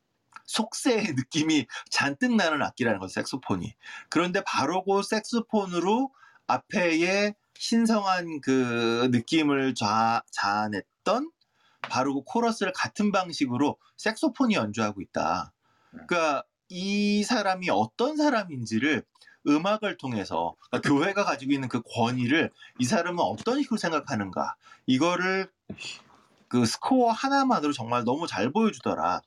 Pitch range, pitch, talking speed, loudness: 135-230 Hz, 190 Hz, 295 characters per minute, -26 LUFS